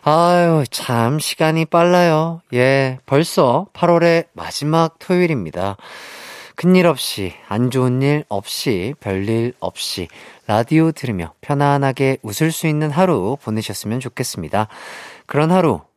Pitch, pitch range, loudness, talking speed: 145 Hz, 115-165 Hz, -17 LUFS, 255 characters per minute